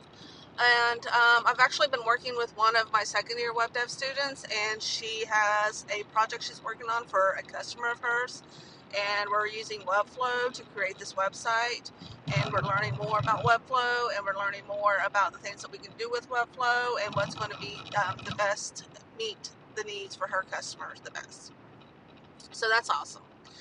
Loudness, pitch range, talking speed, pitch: -29 LUFS, 205-240 Hz, 190 wpm, 225 Hz